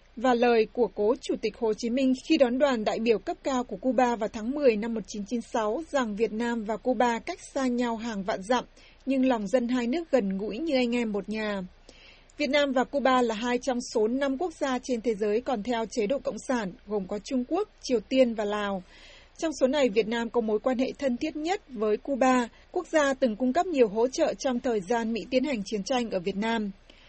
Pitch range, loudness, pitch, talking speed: 225-265 Hz, -27 LUFS, 245 Hz, 235 wpm